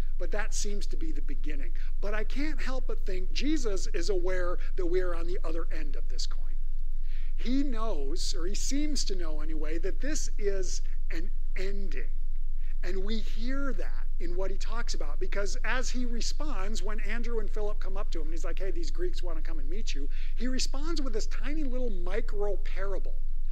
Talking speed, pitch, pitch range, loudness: 205 wpm, 215 Hz, 190-275 Hz, -35 LUFS